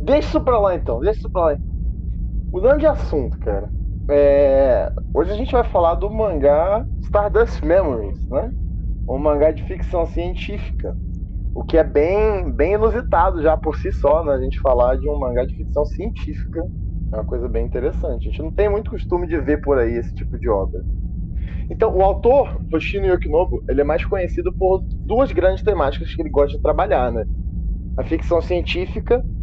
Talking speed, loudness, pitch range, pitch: 185 wpm, -20 LUFS, 130-215 Hz, 165 Hz